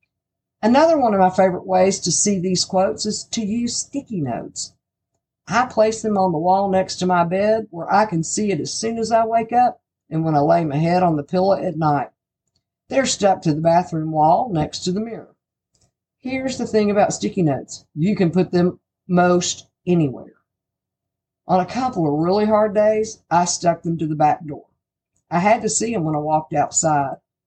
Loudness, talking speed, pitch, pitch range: -19 LUFS, 200 wpm, 185 Hz, 170-215 Hz